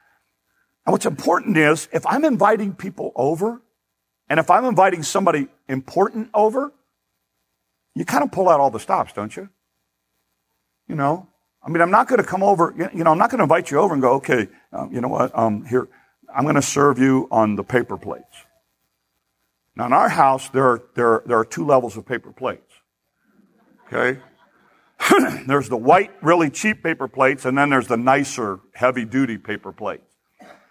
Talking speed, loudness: 185 wpm, -19 LUFS